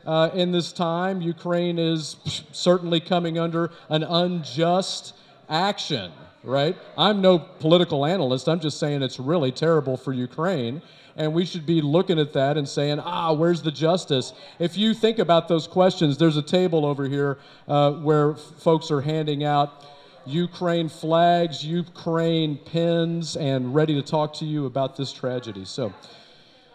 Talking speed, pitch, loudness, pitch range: 155 wpm, 160 Hz, -23 LUFS, 145-170 Hz